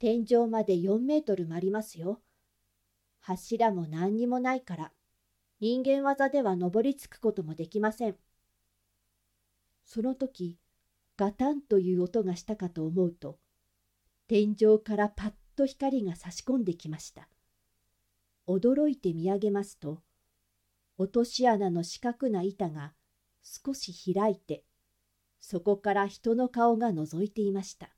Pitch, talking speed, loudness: 185 Hz, 240 characters per minute, -30 LUFS